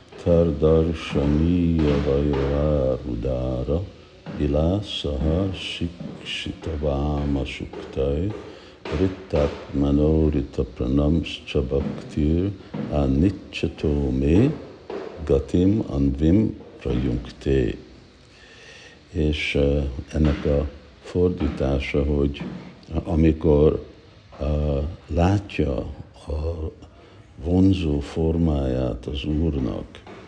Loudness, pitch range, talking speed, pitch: -23 LUFS, 70-85 Hz, 60 wpm, 75 Hz